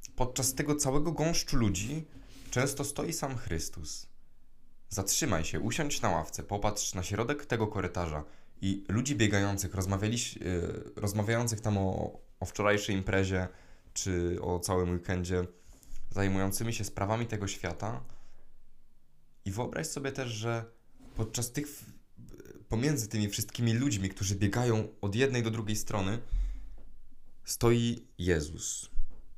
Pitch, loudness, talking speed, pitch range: 105 Hz, -32 LUFS, 115 wpm, 95-120 Hz